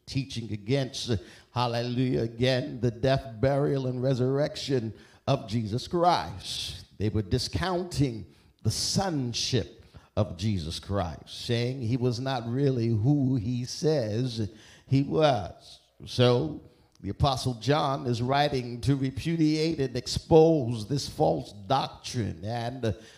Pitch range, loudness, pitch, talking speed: 110-135 Hz, -28 LUFS, 125 Hz, 115 wpm